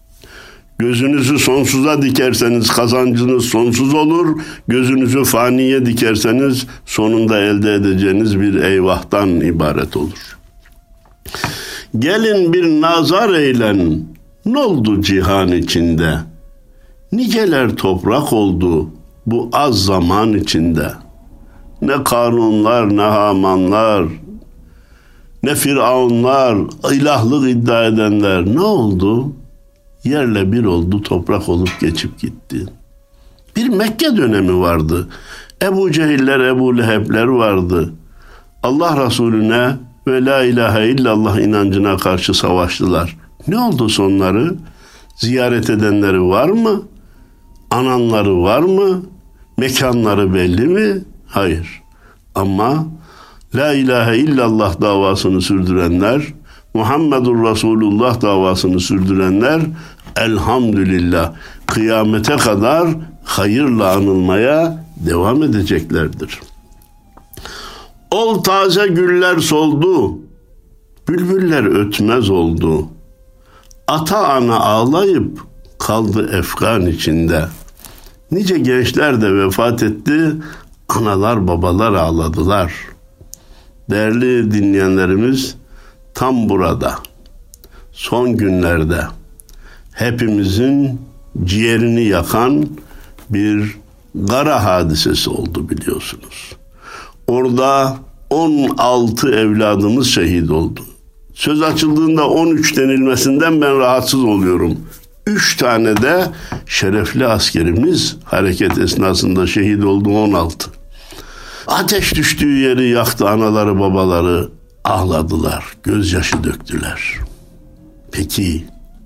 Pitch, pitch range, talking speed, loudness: 110 Hz, 95-130 Hz, 85 wpm, -14 LUFS